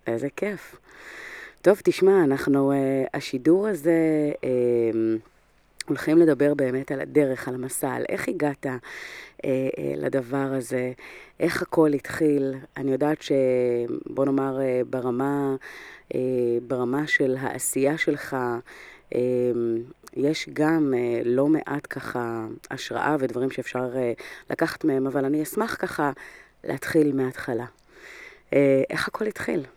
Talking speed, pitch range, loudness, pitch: 100 wpm, 125-145 Hz, -25 LUFS, 135 Hz